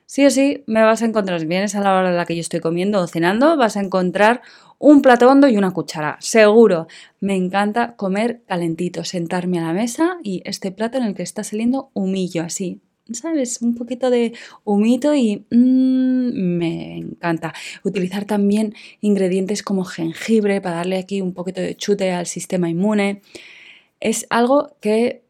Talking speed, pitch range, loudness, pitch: 180 wpm, 180-235 Hz, -18 LUFS, 205 Hz